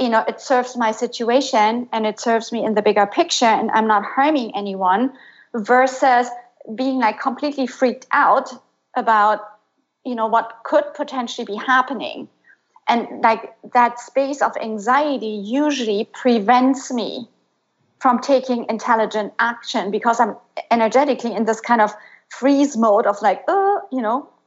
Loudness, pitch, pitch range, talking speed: -19 LUFS, 240 Hz, 220-260 Hz, 150 wpm